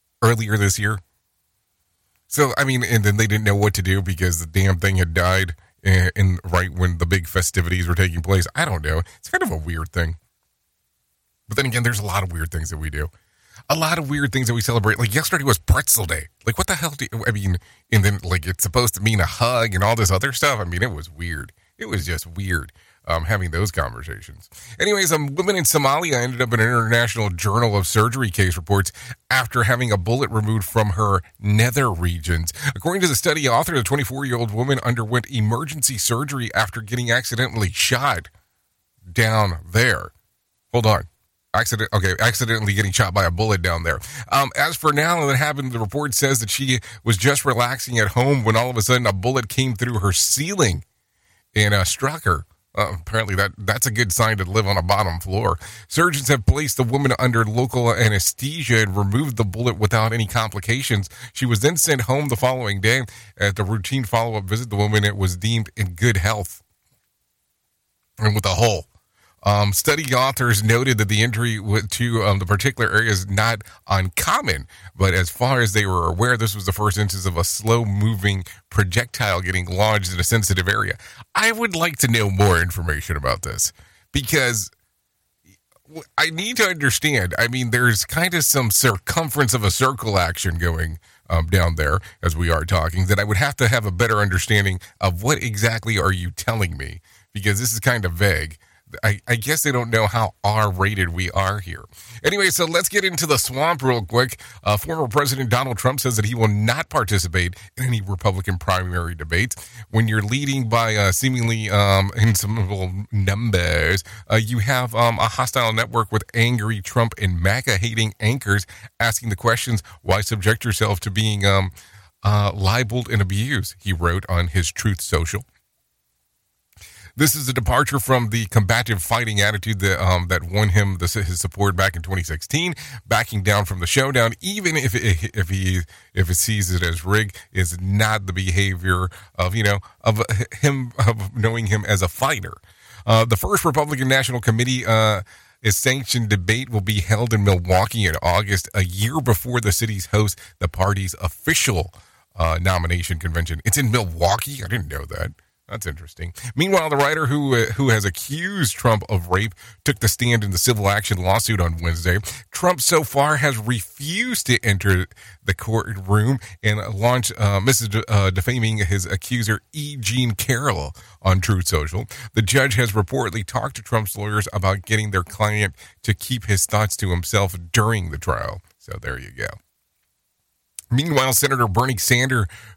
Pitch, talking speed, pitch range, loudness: 105 Hz, 185 wpm, 95-120 Hz, -20 LUFS